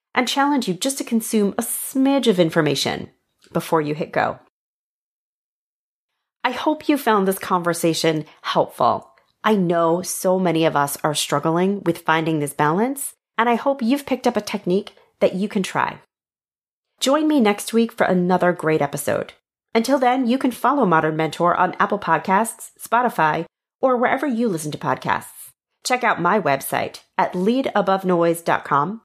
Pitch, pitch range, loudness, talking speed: 195 Hz, 165-240 Hz, -20 LUFS, 155 wpm